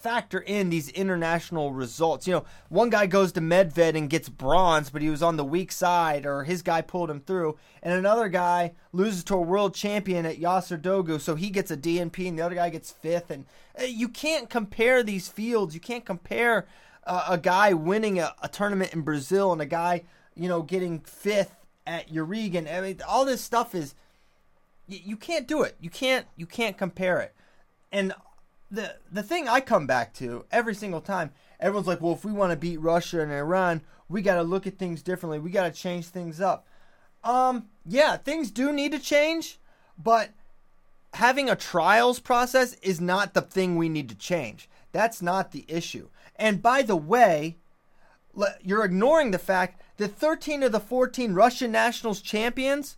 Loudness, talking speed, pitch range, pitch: -26 LUFS, 190 wpm, 170-220 Hz, 185 Hz